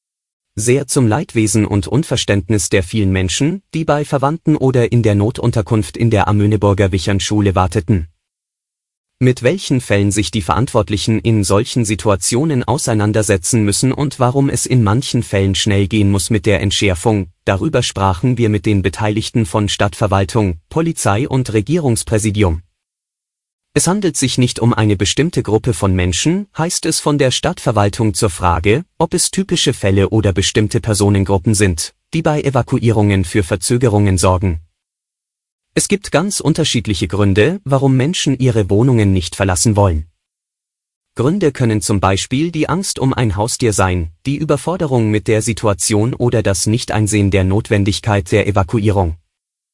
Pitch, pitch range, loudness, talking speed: 110 Hz, 100-130 Hz, -15 LUFS, 145 wpm